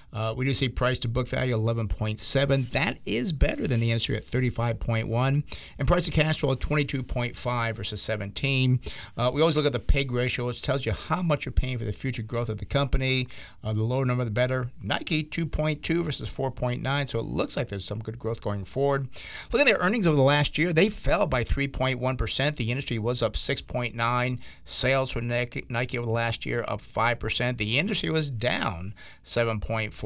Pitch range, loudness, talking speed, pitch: 115-140 Hz, -27 LUFS, 240 wpm, 125 Hz